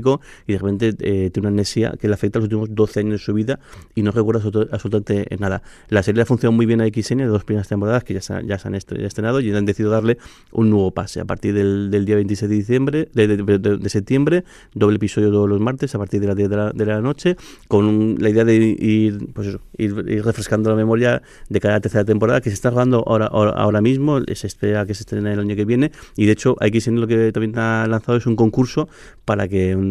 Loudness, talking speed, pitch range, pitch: -19 LUFS, 260 wpm, 105-115 Hz, 105 Hz